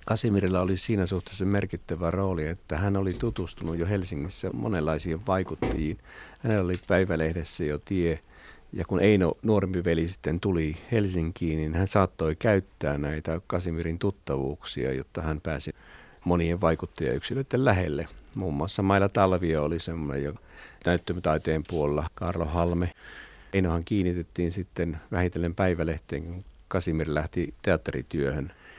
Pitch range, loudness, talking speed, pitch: 80-95 Hz, -28 LUFS, 125 wpm, 85 Hz